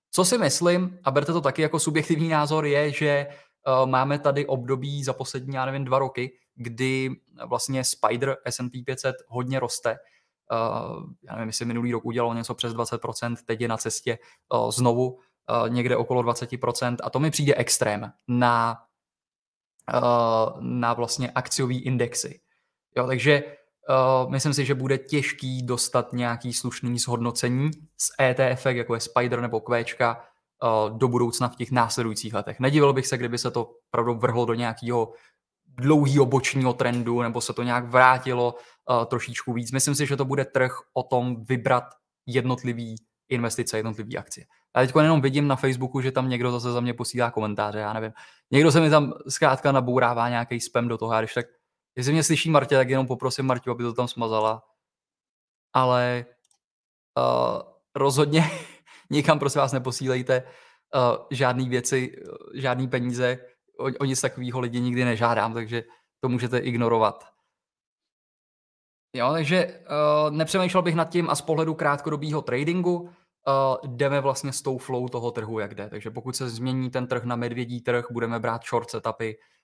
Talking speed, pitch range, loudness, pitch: 160 wpm, 120-135 Hz, -24 LUFS, 125 Hz